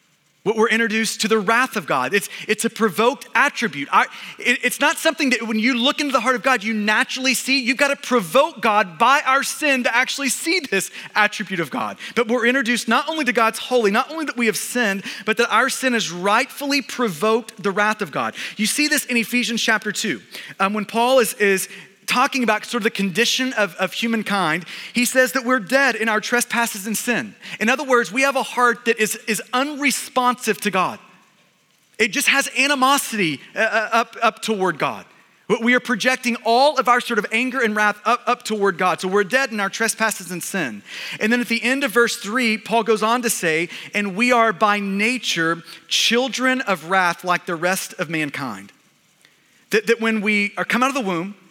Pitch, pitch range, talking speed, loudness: 225 Hz, 205-255 Hz, 210 wpm, -19 LUFS